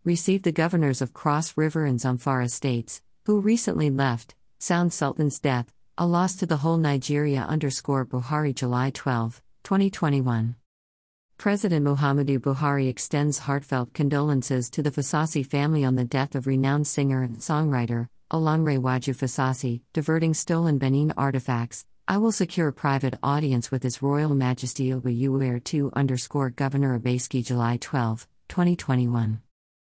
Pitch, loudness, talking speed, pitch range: 135 Hz, -25 LUFS, 140 wpm, 125-150 Hz